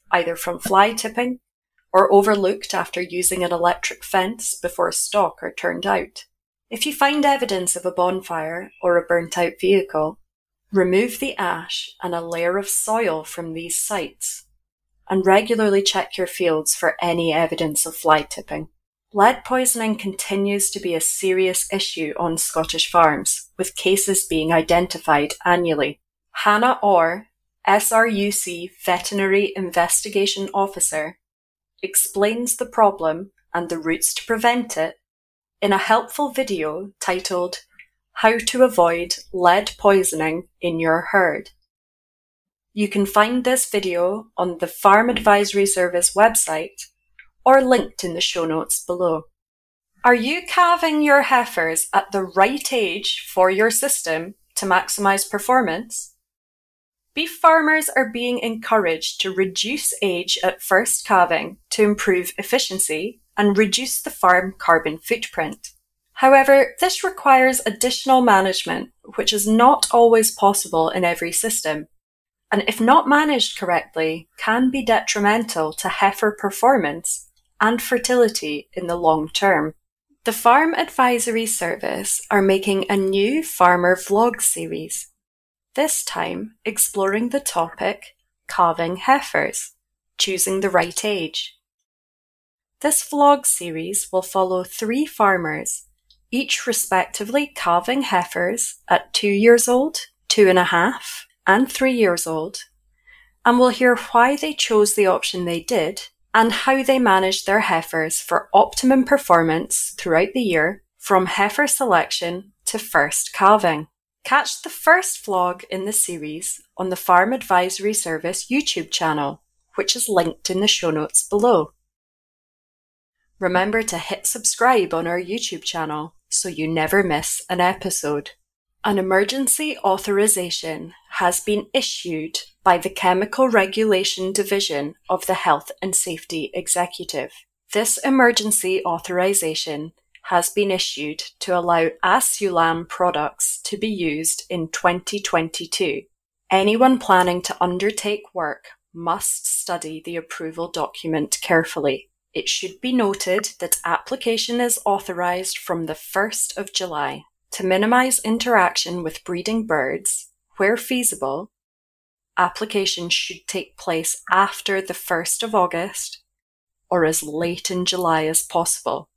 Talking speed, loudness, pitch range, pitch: 130 wpm, -19 LUFS, 175-230 Hz, 195 Hz